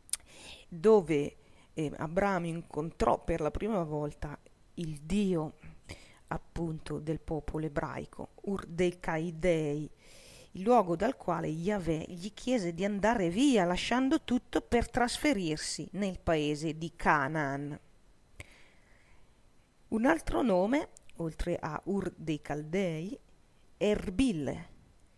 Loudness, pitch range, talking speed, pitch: -32 LUFS, 155-205 Hz, 105 wpm, 170 Hz